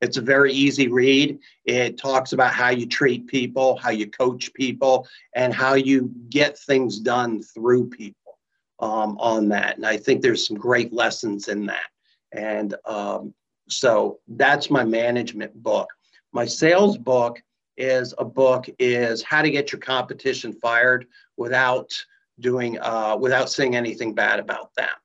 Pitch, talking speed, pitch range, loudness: 125 Hz, 155 wpm, 115-135 Hz, -21 LUFS